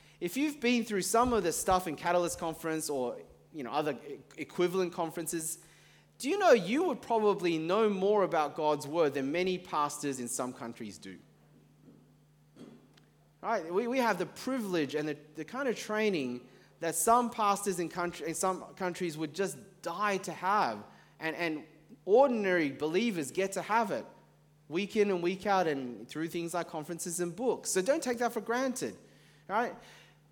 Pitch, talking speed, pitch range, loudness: 175 Hz, 170 wpm, 155-205 Hz, -32 LUFS